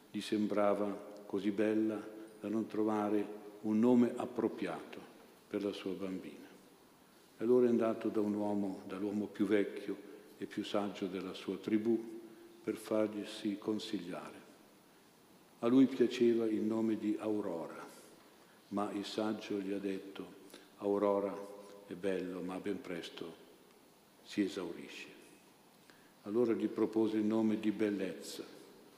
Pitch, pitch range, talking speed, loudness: 105 Hz, 100-110 Hz, 125 wpm, -36 LUFS